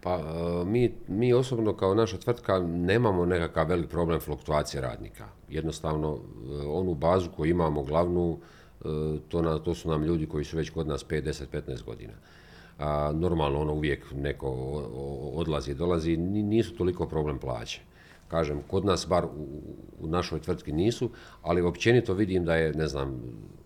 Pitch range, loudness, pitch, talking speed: 75-90 Hz, -29 LUFS, 80 Hz, 155 wpm